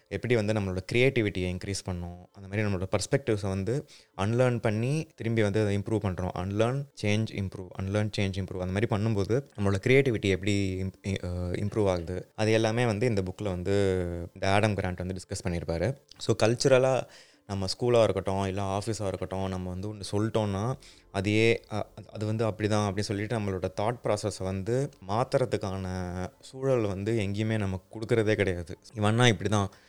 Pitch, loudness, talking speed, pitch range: 105 Hz, -29 LUFS, 155 wpm, 95-115 Hz